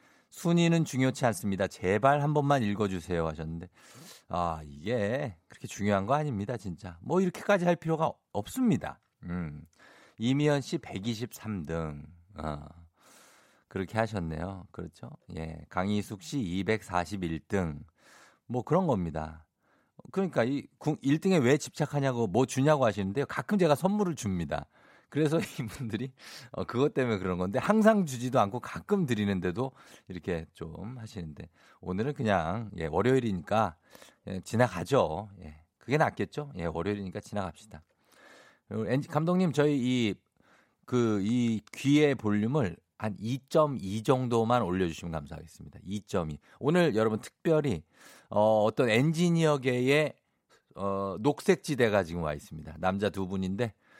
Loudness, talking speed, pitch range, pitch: -30 LUFS, 285 characters per minute, 90-140 Hz, 110 Hz